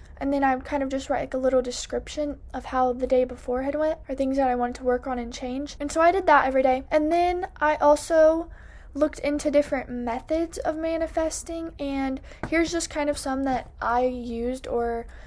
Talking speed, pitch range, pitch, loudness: 215 wpm, 255-315 Hz, 280 Hz, -25 LUFS